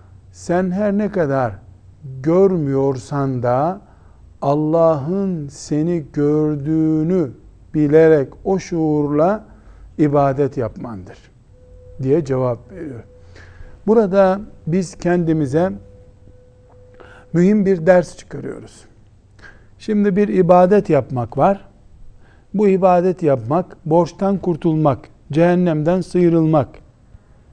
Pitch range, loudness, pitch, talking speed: 120-180 Hz, -17 LUFS, 155 Hz, 80 wpm